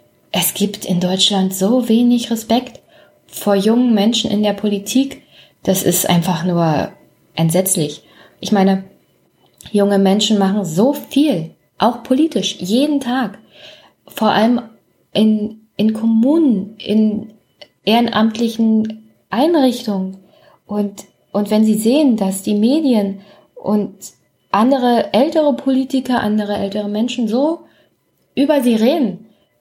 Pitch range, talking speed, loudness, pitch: 200-245 Hz, 115 wpm, -16 LUFS, 215 Hz